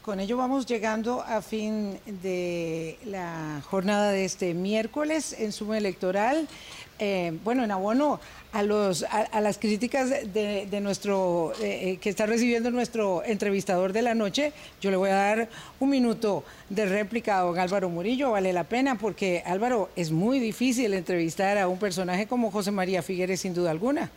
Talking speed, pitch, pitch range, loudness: 170 wpm, 205 Hz, 185-230 Hz, -27 LUFS